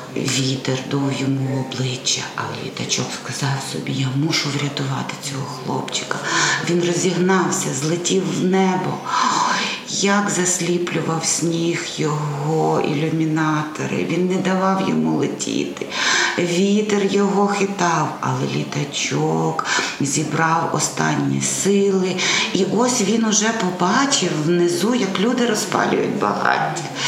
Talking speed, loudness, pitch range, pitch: 105 wpm, -19 LUFS, 140-190 Hz, 170 Hz